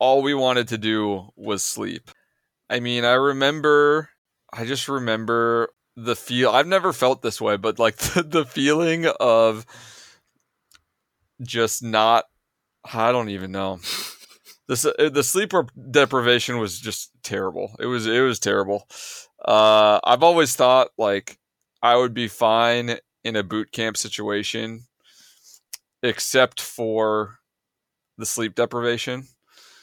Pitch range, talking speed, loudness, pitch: 110-130 Hz, 125 wpm, -21 LUFS, 120 Hz